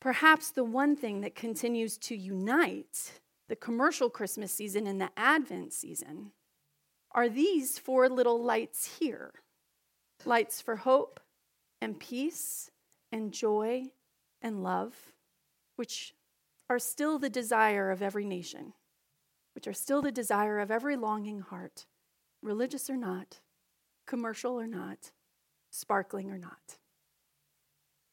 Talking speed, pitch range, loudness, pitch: 120 wpm, 210-265 Hz, -32 LUFS, 235 Hz